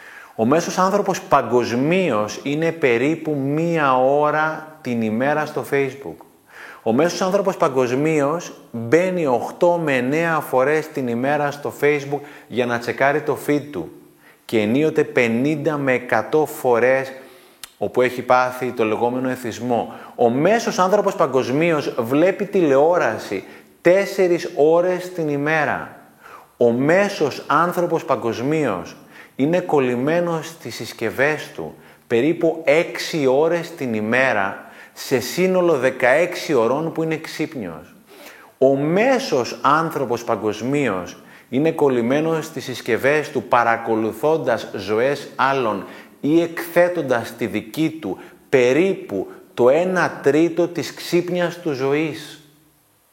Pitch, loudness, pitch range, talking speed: 150 Hz, -19 LUFS, 130-165 Hz, 110 wpm